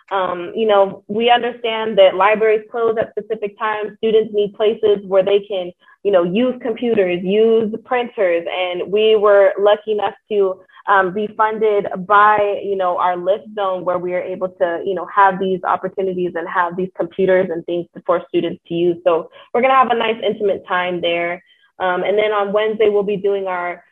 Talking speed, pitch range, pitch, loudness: 190 wpm, 185-215 Hz, 200 Hz, -17 LUFS